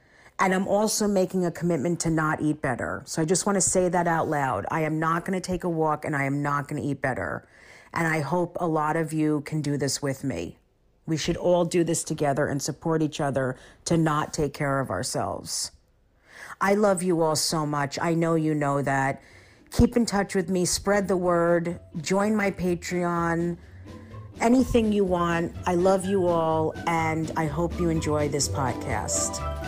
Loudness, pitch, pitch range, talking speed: -25 LUFS, 160 Hz, 145-175 Hz, 200 wpm